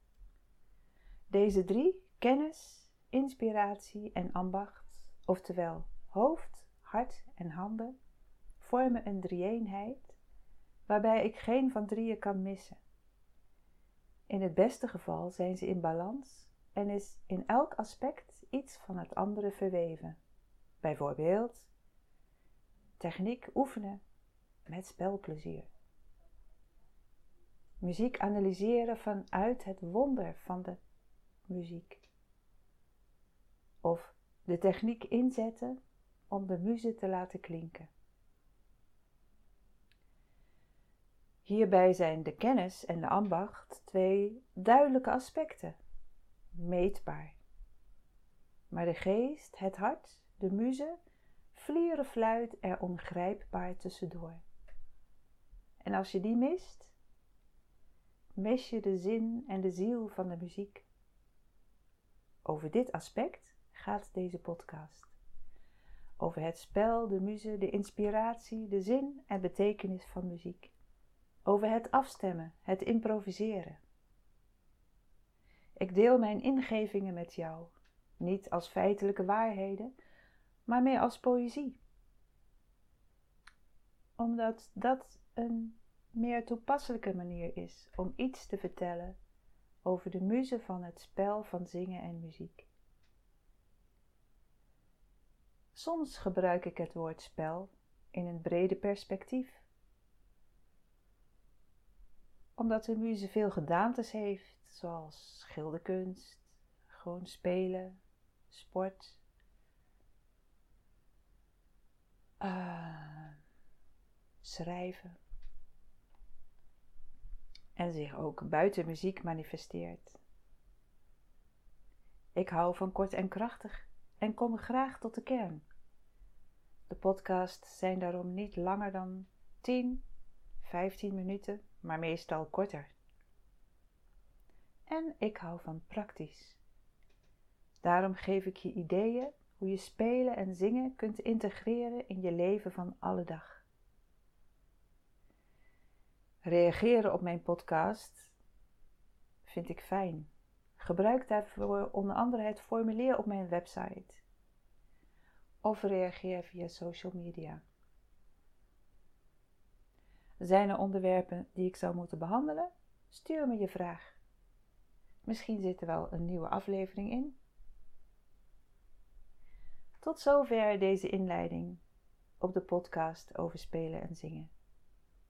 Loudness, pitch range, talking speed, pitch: -36 LUFS, 165-220 Hz, 100 wpm, 190 Hz